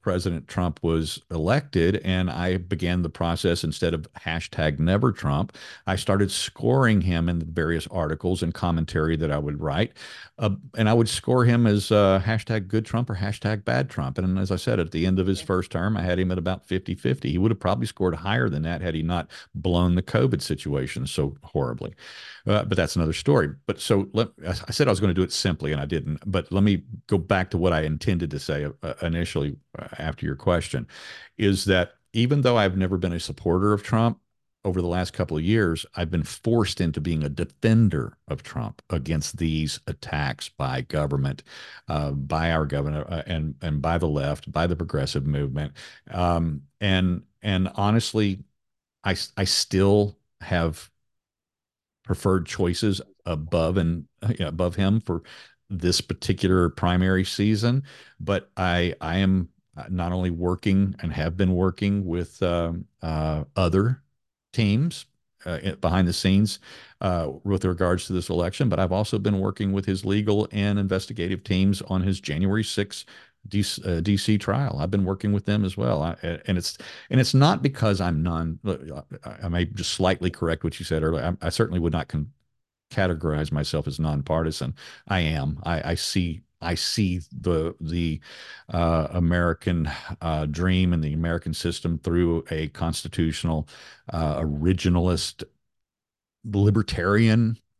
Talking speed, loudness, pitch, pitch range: 175 wpm, -25 LUFS, 90 Hz, 80-100 Hz